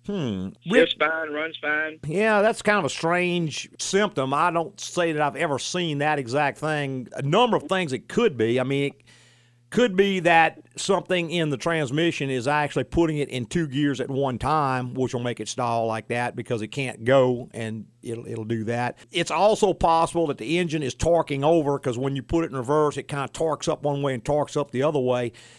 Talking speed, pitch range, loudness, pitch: 215 wpm, 125-165 Hz, -24 LUFS, 145 Hz